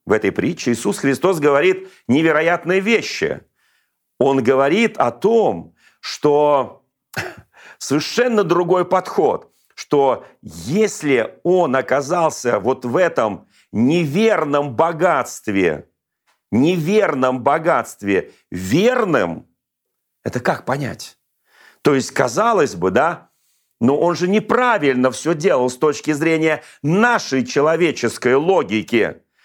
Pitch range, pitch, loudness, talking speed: 135-185 Hz, 160 Hz, -17 LUFS, 100 wpm